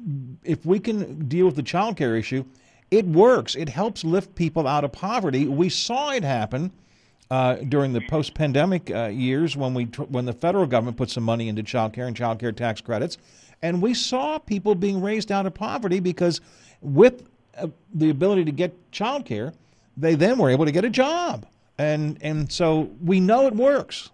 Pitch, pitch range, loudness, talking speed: 160 Hz, 130-190 Hz, -23 LUFS, 195 wpm